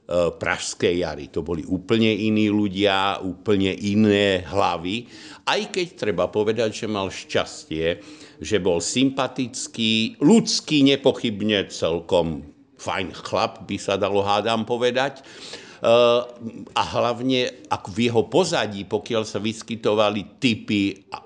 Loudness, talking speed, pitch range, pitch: -22 LUFS, 115 wpm, 100-125 Hz, 110 Hz